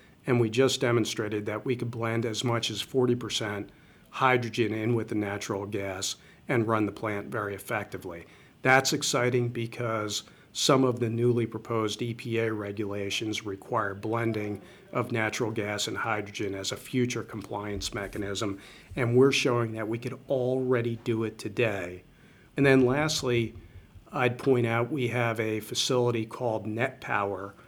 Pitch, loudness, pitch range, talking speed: 115 Hz, -28 LUFS, 105-125 Hz, 145 wpm